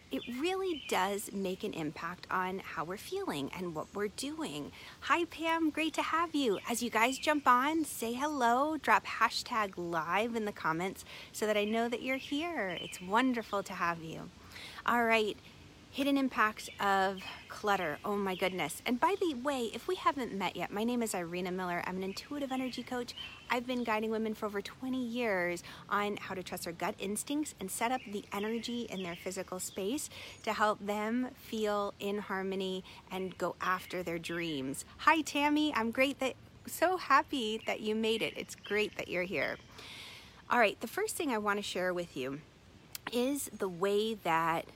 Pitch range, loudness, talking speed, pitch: 185-255 Hz, -34 LUFS, 185 wpm, 215 Hz